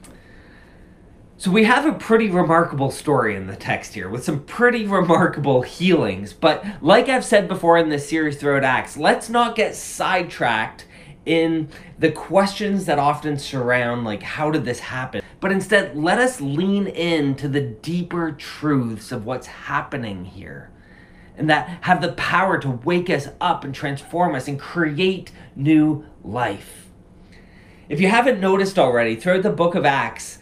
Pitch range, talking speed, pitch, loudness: 135-185 Hz, 160 wpm, 160 Hz, -20 LUFS